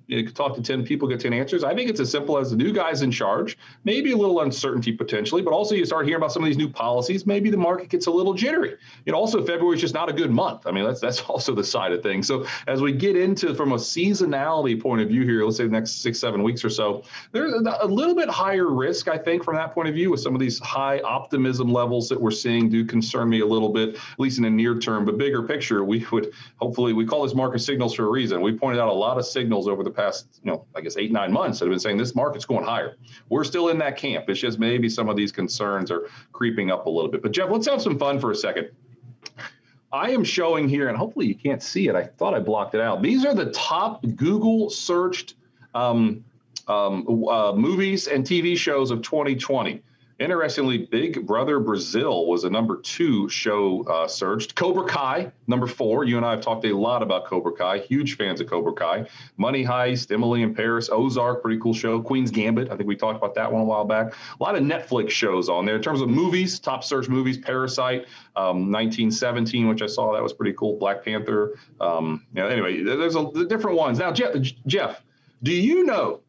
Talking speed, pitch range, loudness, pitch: 240 wpm, 115-160 Hz, -23 LUFS, 125 Hz